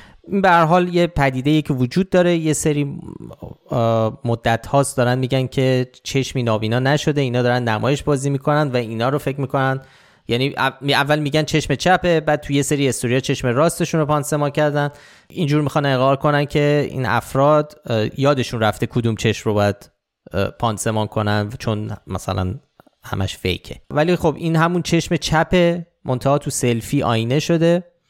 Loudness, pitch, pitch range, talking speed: -19 LUFS, 140 Hz, 120-155 Hz, 160 wpm